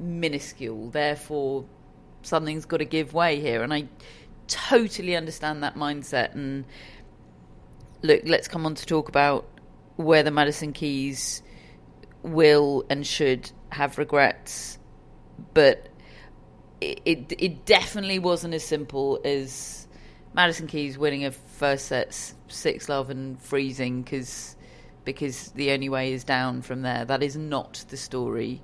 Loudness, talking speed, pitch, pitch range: -25 LUFS, 135 wpm, 140 Hz, 130-155 Hz